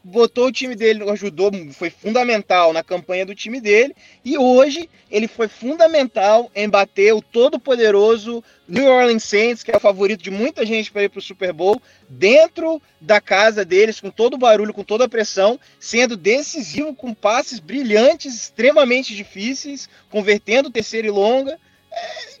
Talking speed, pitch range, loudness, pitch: 165 wpm, 205-260 Hz, -17 LUFS, 225 Hz